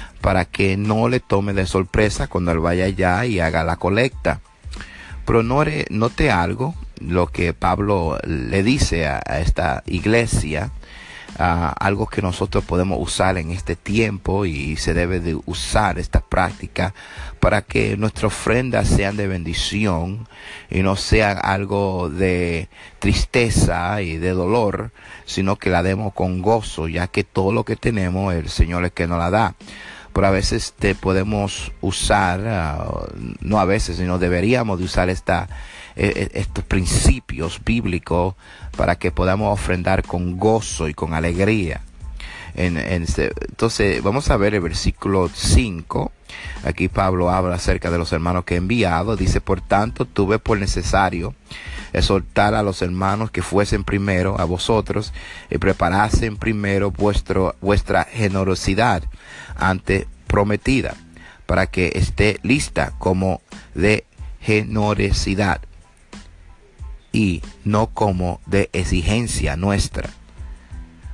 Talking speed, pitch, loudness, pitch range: 135 wpm, 95 Hz, -20 LUFS, 85-105 Hz